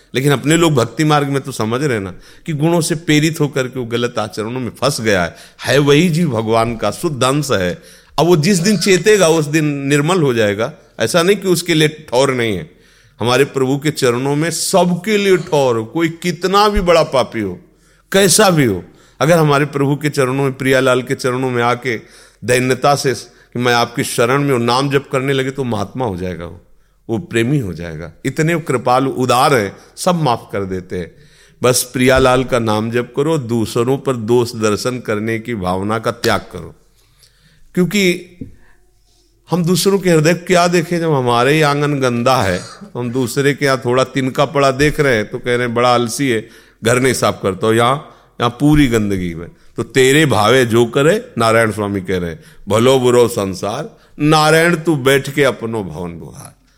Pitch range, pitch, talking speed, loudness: 115-155 Hz, 130 Hz, 190 wpm, -15 LUFS